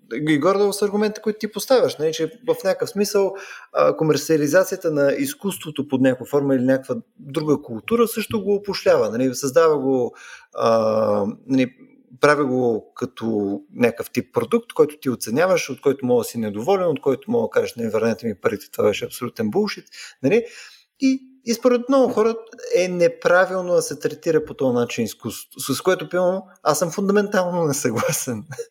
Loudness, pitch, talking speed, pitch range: -21 LUFS, 180 Hz, 170 wpm, 135-225 Hz